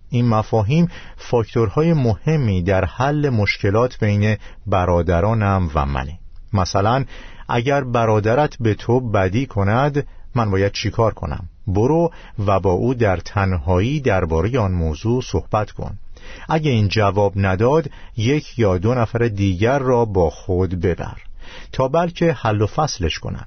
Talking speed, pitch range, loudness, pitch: 135 wpm, 95-125 Hz, -19 LUFS, 110 Hz